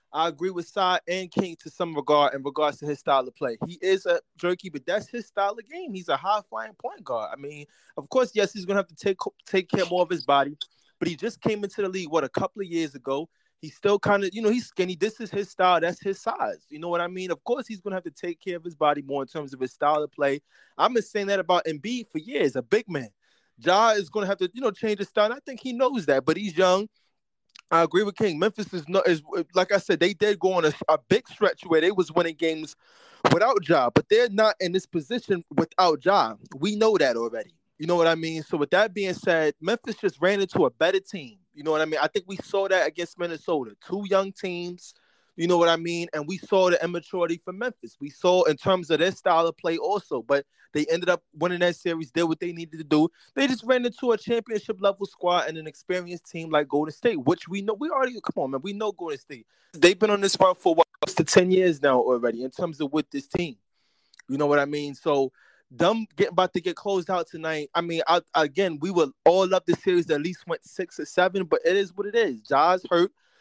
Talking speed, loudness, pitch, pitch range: 265 wpm, -25 LUFS, 180 Hz, 160-205 Hz